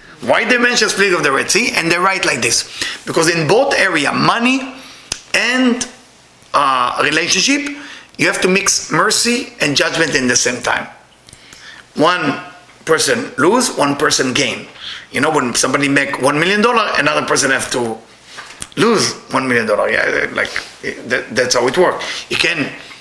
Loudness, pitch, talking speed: -14 LUFS, 185 Hz, 165 wpm